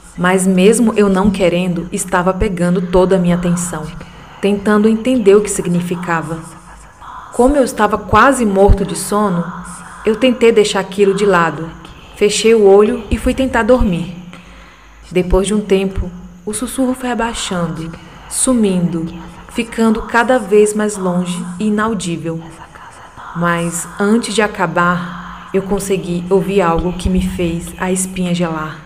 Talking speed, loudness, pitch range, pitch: 135 wpm, -14 LUFS, 175-210 Hz, 190 Hz